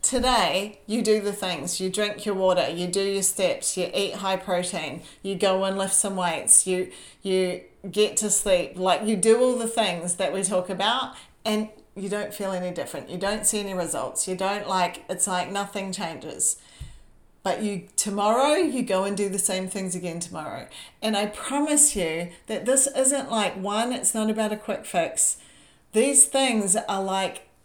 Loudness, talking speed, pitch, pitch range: -24 LUFS, 190 wpm, 195 Hz, 185-215 Hz